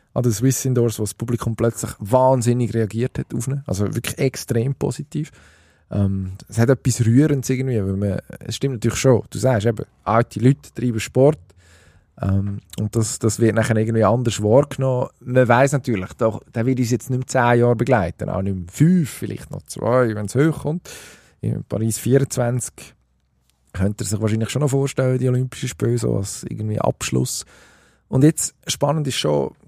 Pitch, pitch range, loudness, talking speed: 120 Hz, 105-130 Hz, -20 LUFS, 180 wpm